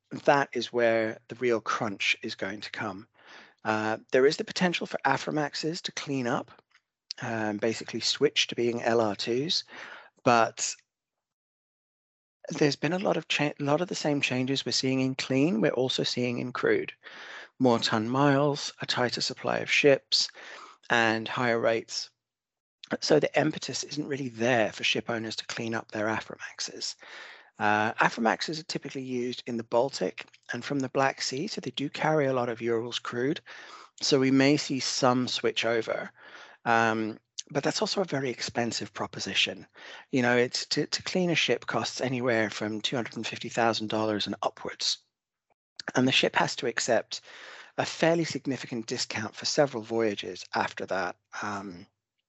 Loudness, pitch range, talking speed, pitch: -28 LUFS, 115-145 Hz, 160 wpm, 125 Hz